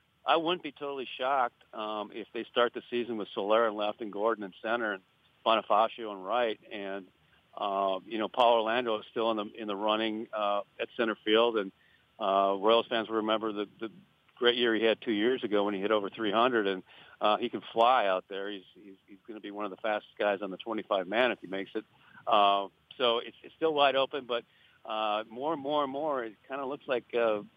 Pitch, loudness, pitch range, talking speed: 110 Hz, -30 LUFS, 100-120 Hz, 230 wpm